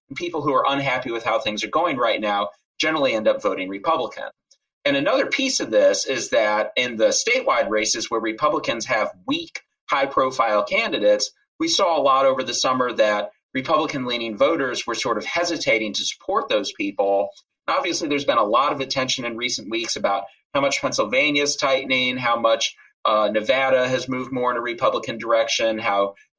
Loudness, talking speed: -21 LUFS, 185 wpm